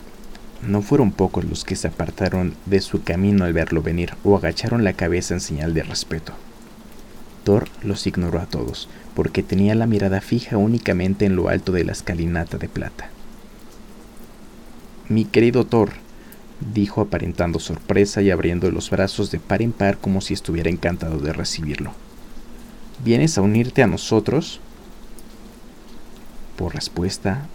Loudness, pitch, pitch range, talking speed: -21 LUFS, 95 Hz, 85-105 Hz, 145 wpm